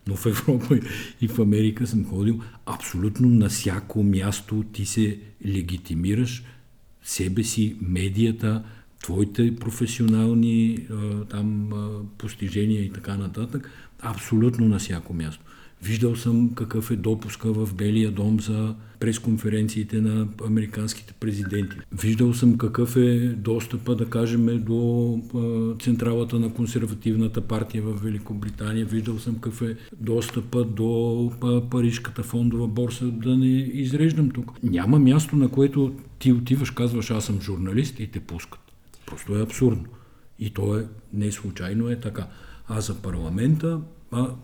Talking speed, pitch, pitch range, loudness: 130 wpm, 110 Hz, 105-120 Hz, -24 LUFS